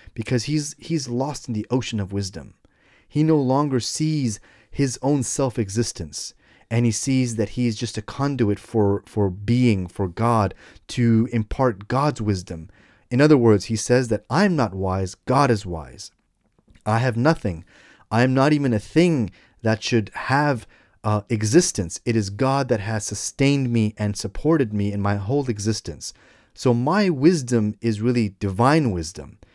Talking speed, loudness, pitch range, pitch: 165 wpm, -22 LUFS, 105-135 Hz, 115 Hz